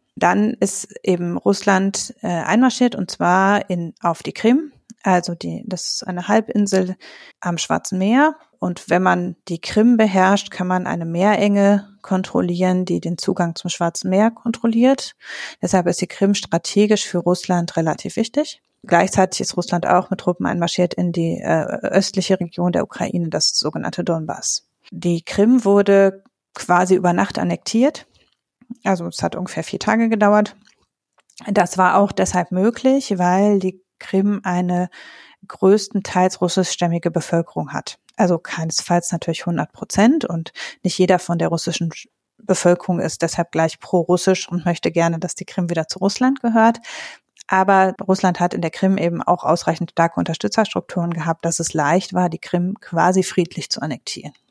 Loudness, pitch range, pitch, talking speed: -19 LUFS, 175-205 Hz, 185 Hz, 150 wpm